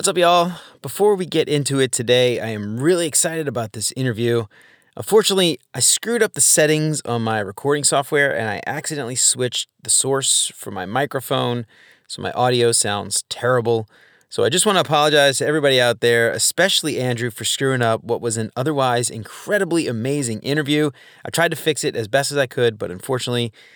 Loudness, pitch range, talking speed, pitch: -18 LUFS, 120-155 Hz, 185 wpm, 135 Hz